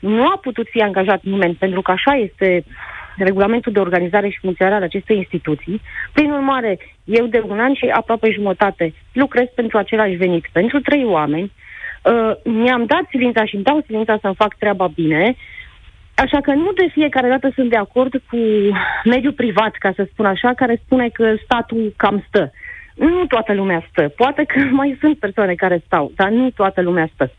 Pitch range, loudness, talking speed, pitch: 195-255 Hz, -16 LUFS, 185 wpm, 220 Hz